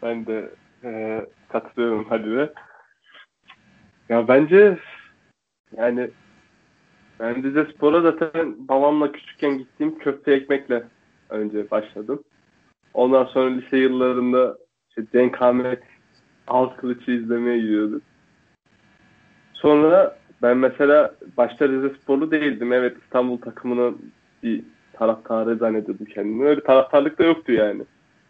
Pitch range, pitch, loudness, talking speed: 115-145 Hz, 125 Hz, -20 LUFS, 105 wpm